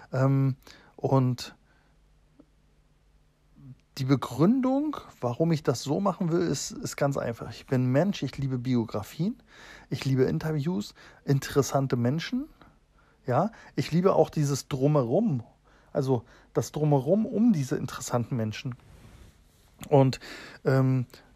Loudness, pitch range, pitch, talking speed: -27 LUFS, 130-165 Hz, 140 Hz, 110 wpm